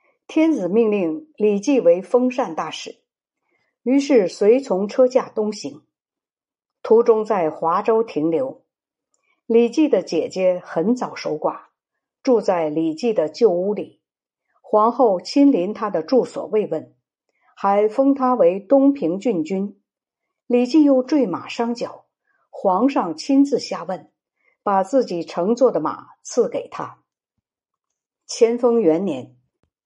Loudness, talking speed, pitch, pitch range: -19 LUFS, 175 characters per minute, 230 Hz, 185-265 Hz